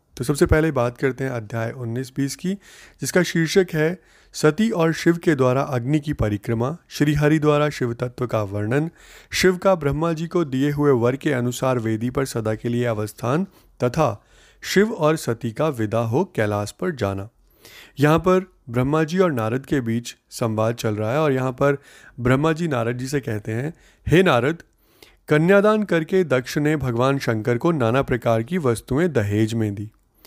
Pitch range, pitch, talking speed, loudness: 120-160 Hz, 135 Hz, 180 wpm, -21 LUFS